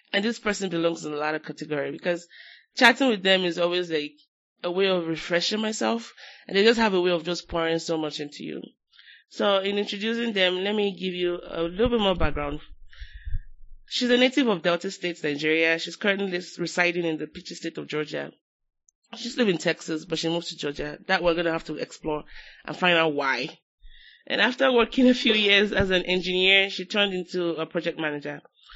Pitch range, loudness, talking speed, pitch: 160-200 Hz, -24 LUFS, 205 wpm, 175 Hz